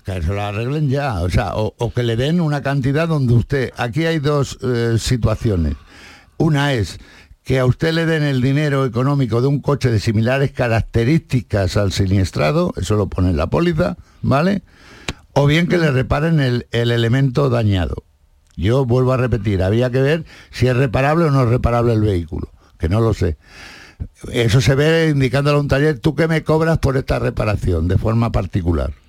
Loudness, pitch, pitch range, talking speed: -17 LUFS, 125 Hz, 105-140 Hz, 190 wpm